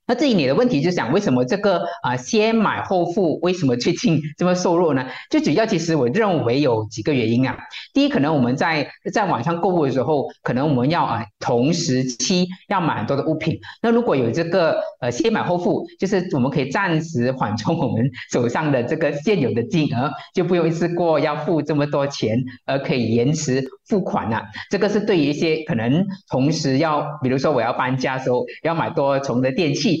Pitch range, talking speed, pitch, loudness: 130-185 Hz, 320 characters per minute, 155 Hz, -20 LUFS